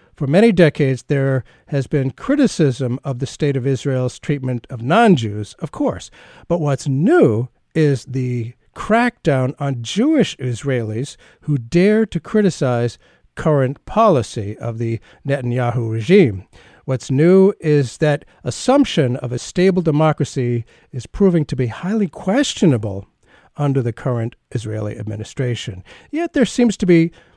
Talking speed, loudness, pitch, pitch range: 135 wpm, -18 LUFS, 140 Hz, 120-170 Hz